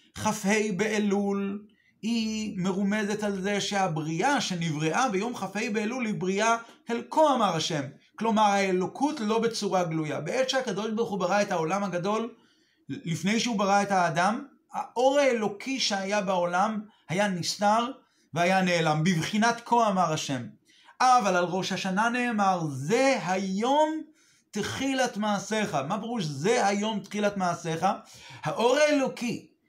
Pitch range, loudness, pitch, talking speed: 185-235 Hz, -27 LUFS, 210 Hz, 130 wpm